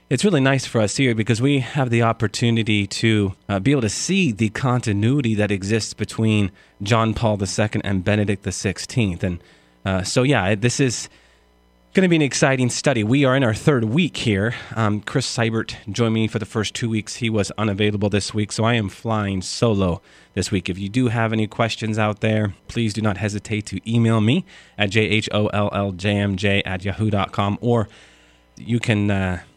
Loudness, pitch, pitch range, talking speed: -20 LUFS, 110 Hz, 100-115 Hz, 185 wpm